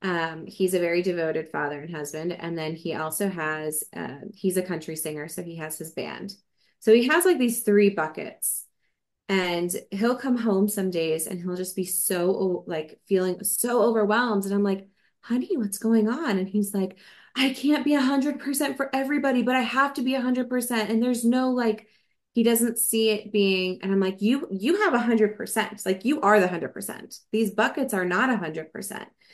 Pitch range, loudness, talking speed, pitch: 180-240 Hz, -25 LUFS, 210 wpm, 205 Hz